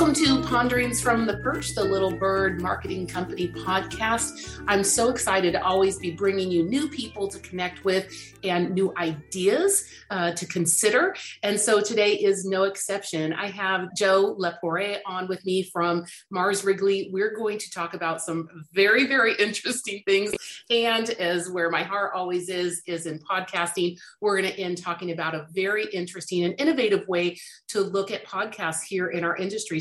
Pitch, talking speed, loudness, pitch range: 190 Hz, 175 wpm, -25 LUFS, 175-205 Hz